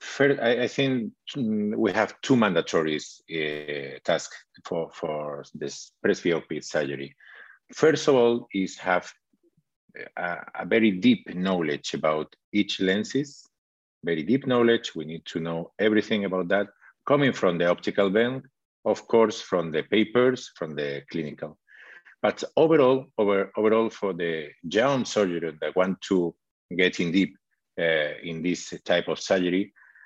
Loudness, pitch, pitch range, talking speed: -25 LUFS, 100 Hz, 85-120 Hz, 140 wpm